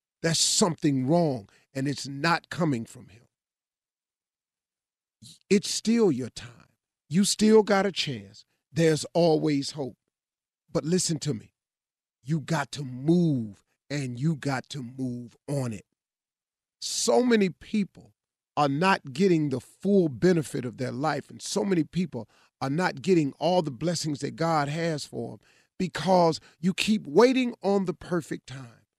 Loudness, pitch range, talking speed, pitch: -26 LUFS, 135-180 Hz, 145 wpm, 155 Hz